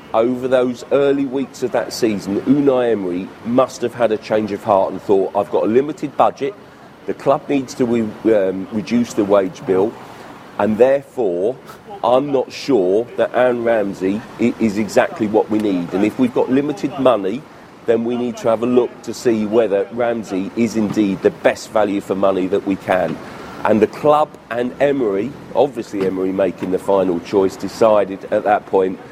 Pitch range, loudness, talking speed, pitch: 100-125 Hz, -18 LUFS, 180 wpm, 110 Hz